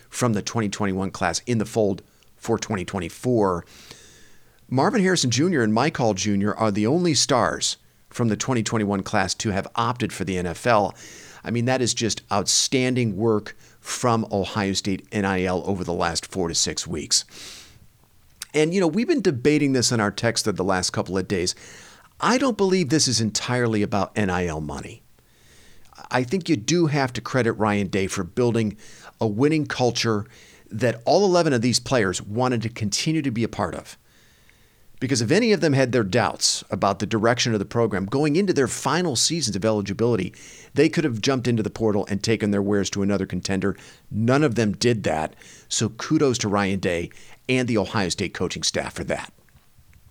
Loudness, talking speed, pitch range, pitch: -22 LUFS, 185 wpm, 100-130 Hz, 110 Hz